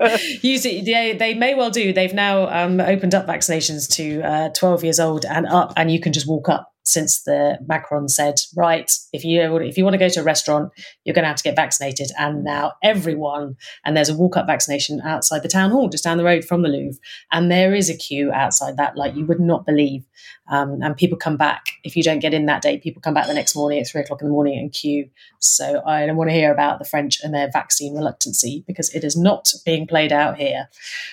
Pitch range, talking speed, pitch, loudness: 145-175 Hz, 245 wpm, 160 Hz, -18 LUFS